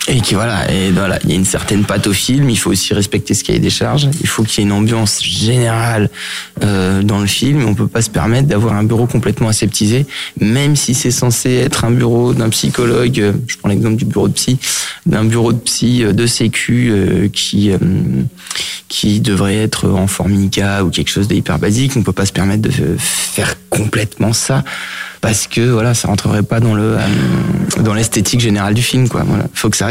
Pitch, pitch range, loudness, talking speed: 110 Hz, 100-120 Hz, -13 LUFS, 225 wpm